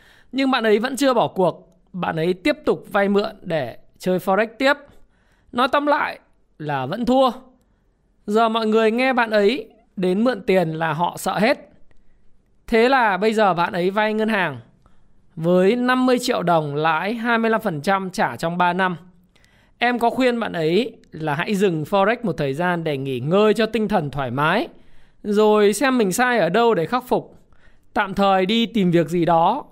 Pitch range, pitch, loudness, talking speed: 175-230 Hz, 210 Hz, -20 LUFS, 185 wpm